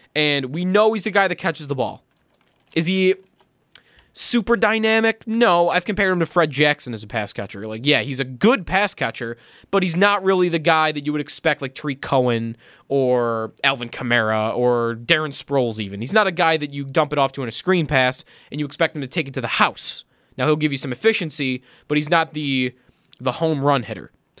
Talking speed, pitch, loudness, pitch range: 220 wpm, 150 Hz, -20 LUFS, 130-175 Hz